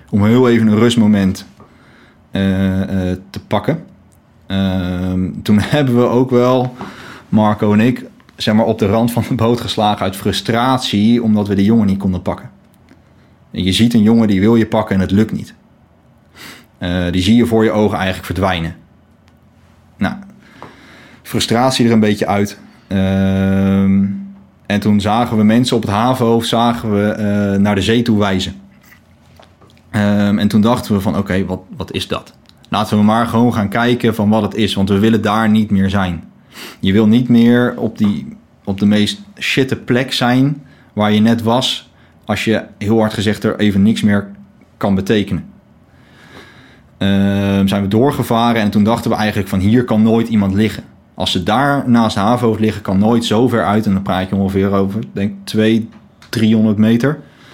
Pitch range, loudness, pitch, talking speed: 100-115 Hz, -14 LUFS, 105 Hz, 180 wpm